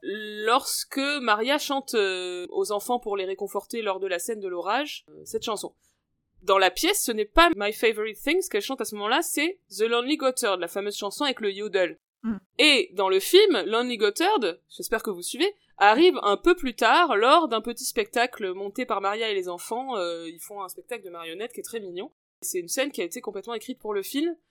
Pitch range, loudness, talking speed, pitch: 200-320 Hz, -25 LUFS, 210 wpm, 230 Hz